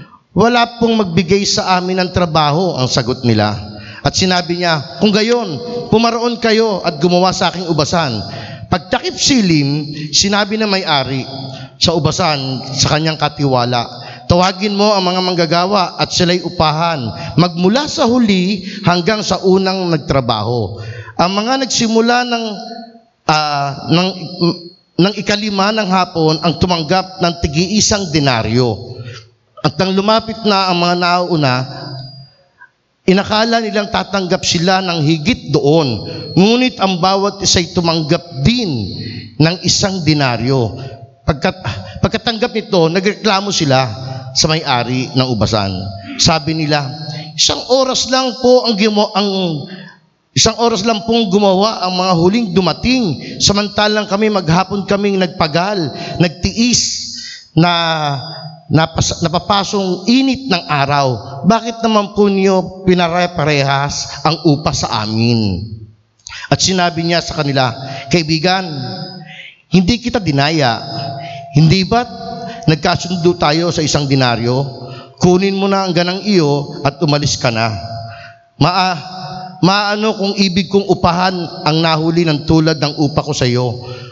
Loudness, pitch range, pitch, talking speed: -14 LUFS, 140-195 Hz, 170 Hz, 125 wpm